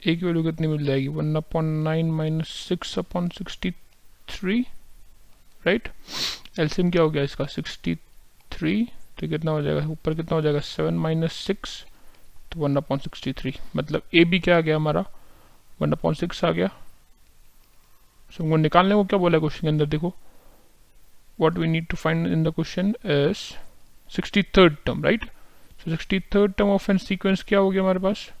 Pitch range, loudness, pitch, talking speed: 150-185 Hz, -24 LUFS, 165 Hz, 125 wpm